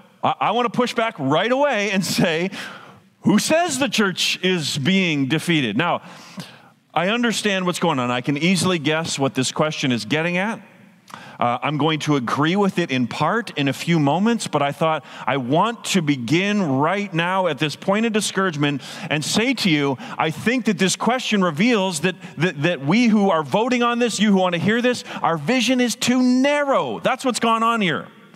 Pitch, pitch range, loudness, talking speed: 185 Hz, 155-225 Hz, -20 LUFS, 200 wpm